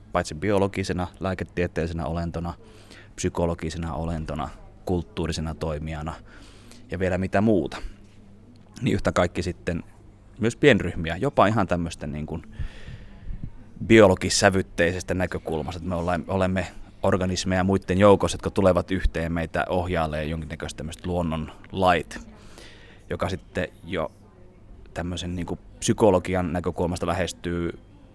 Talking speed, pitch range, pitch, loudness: 105 wpm, 85-100 Hz, 90 Hz, -25 LUFS